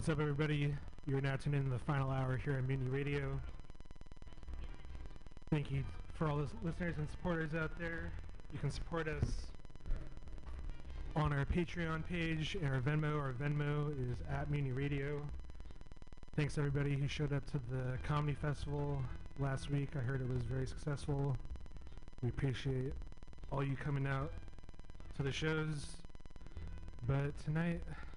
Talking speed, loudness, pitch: 150 wpm, -40 LUFS, 135 Hz